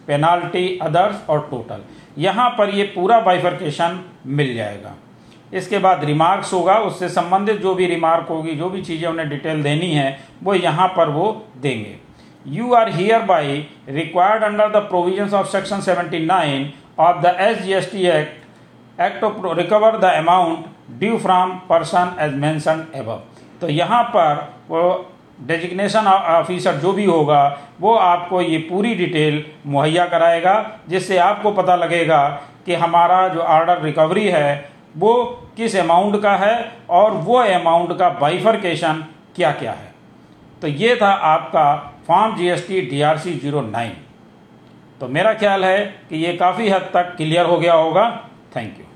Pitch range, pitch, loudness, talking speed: 155-195 Hz, 175 Hz, -17 LUFS, 155 wpm